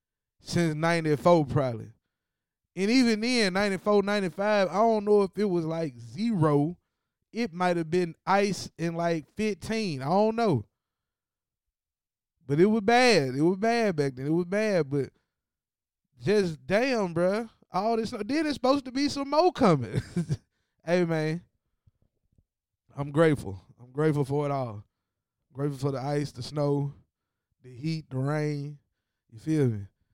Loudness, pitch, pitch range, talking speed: -27 LUFS, 160 Hz, 135-205 Hz, 150 wpm